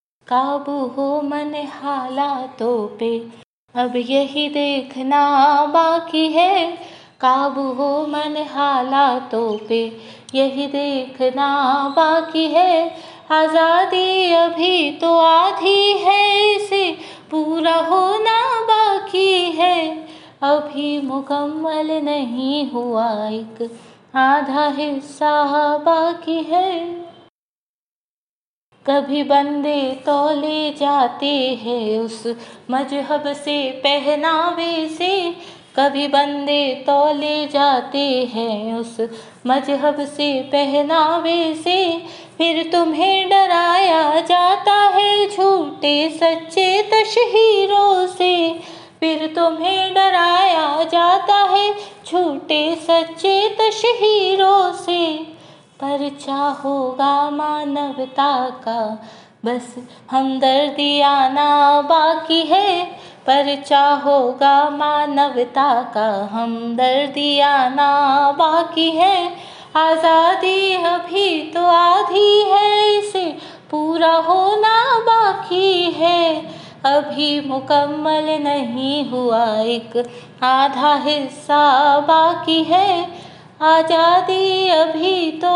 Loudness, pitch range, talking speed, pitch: -16 LUFS, 280-350 Hz, 80 wpm, 300 Hz